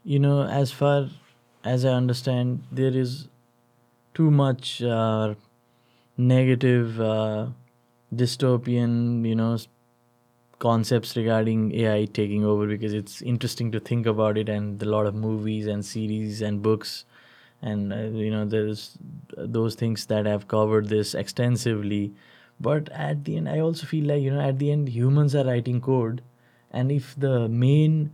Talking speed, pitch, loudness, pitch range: 155 wpm, 120 Hz, -24 LUFS, 110-130 Hz